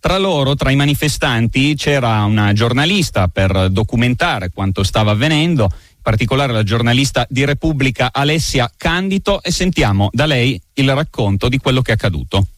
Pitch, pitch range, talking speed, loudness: 130 Hz, 110-145 Hz, 155 wpm, -15 LUFS